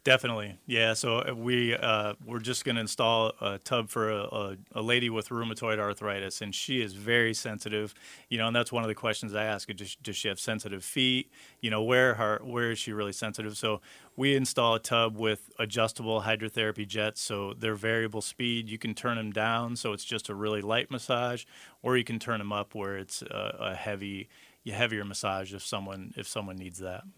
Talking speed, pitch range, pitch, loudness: 210 wpm, 105-120 Hz, 110 Hz, -30 LUFS